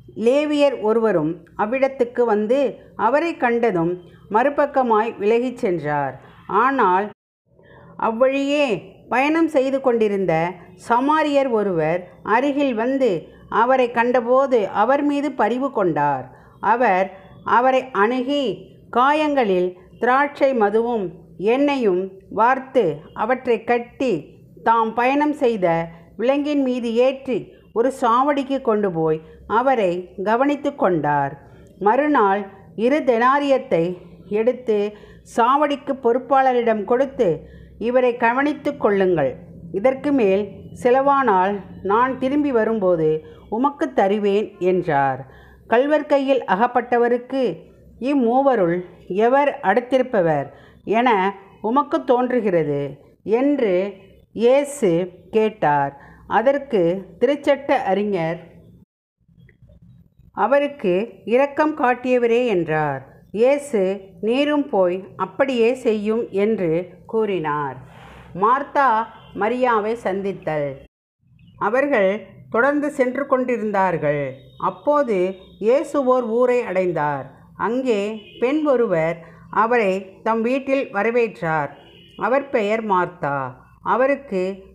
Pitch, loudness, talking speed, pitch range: 225 Hz, -20 LUFS, 80 wpm, 185-265 Hz